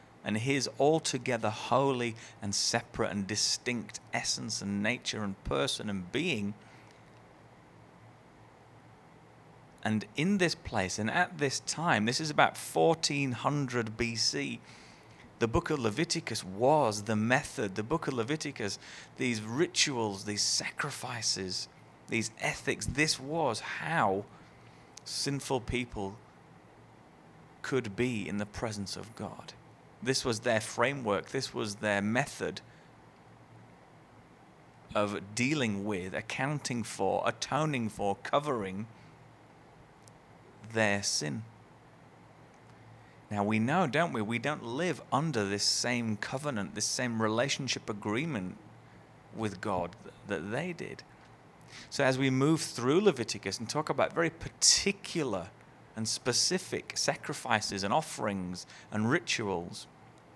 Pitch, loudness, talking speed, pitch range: 120 Hz, -31 LUFS, 115 wpm, 105-135 Hz